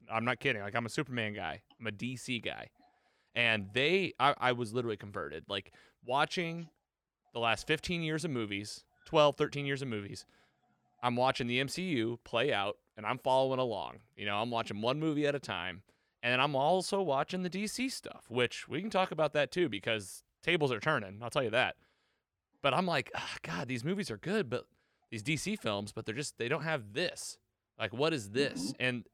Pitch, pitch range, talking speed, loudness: 125 Hz, 115-155 Hz, 200 wpm, -34 LUFS